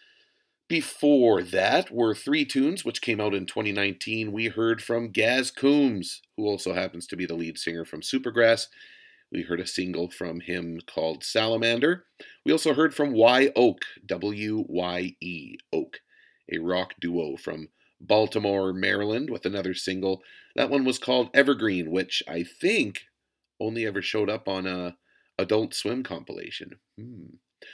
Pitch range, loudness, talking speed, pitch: 90-140 Hz, -26 LUFS, 145 wpm, 110 Hz